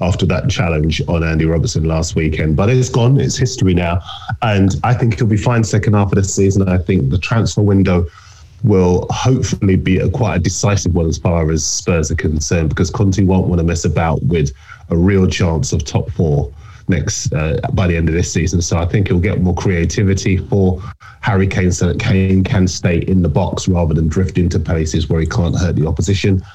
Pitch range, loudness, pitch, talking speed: 85-105 Hz, -15 LUFS, 95 Hz, 215 wpm